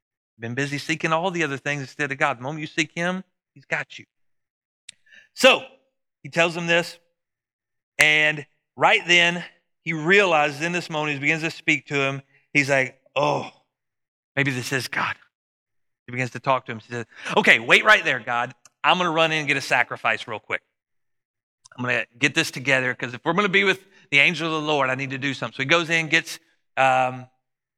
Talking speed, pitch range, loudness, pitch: 210 wpm, 130-170 Hz, -21 LUFS, 150 Hz